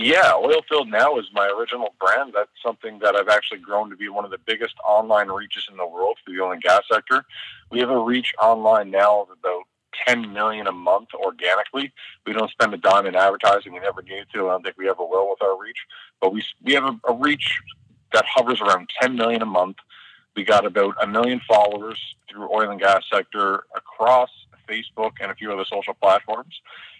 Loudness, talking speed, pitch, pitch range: -20 LUFS, 215 wpm, 110 Hz, 105-125 Hz